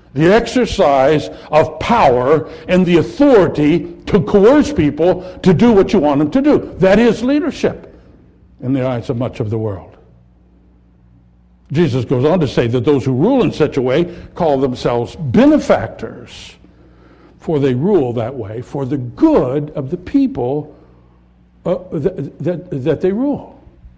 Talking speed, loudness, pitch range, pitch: 155 wpm, -14 LUFS, 115-185 Hz, 150 Hz